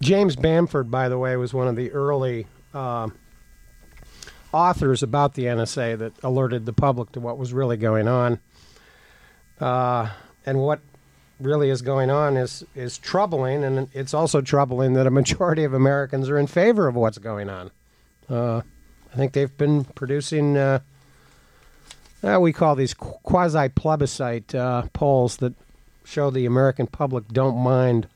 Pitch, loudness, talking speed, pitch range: 135 Hz, -22 LUFS, 155 wpm, 125-145 Hz